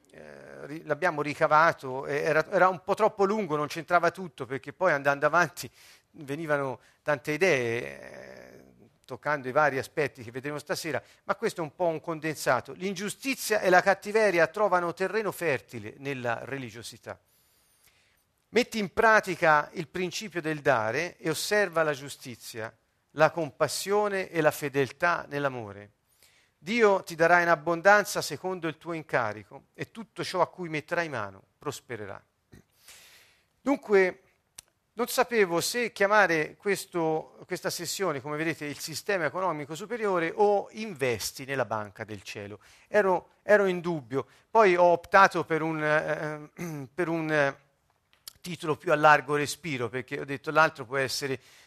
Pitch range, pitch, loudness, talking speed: 140-185 Hz, 155 Hz, -27 LUFS, 135 wpm